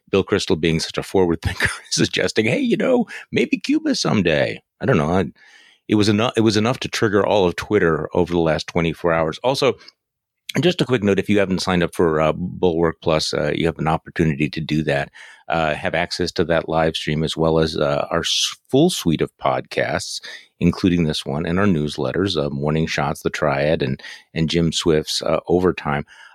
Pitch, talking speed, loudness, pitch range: 85 Hz, 205 wpm, -20 LUFS, 80-100 Hz